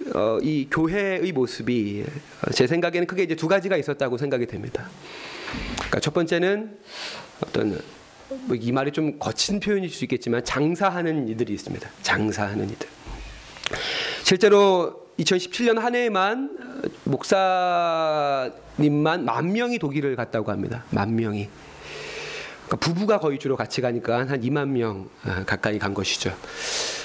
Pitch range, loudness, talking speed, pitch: 120-190 Hz, -24 LUFS, 280 characters per minute, 150 Hz